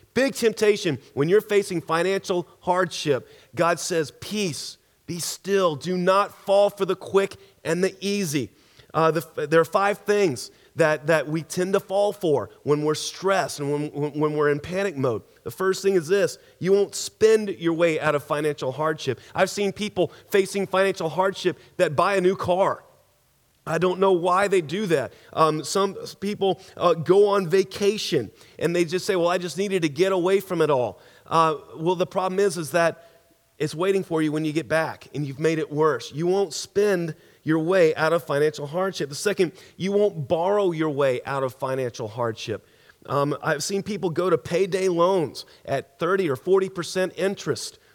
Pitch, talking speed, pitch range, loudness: 175 Hz, 190 wpm, 155-195 Hz, -23 LUFS